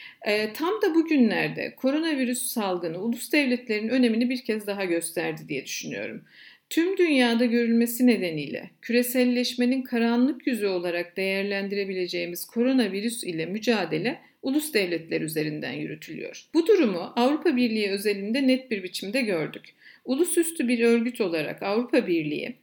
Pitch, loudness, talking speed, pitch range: 235 Hz, -25 LUFS, 120 wpm, 200-260 Hz